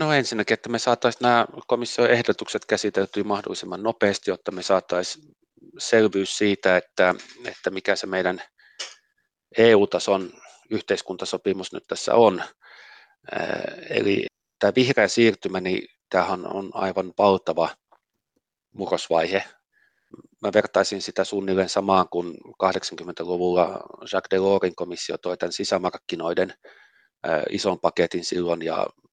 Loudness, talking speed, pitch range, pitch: -23 LUFS, 110 wpm, 95-110 Hz, 100 Hz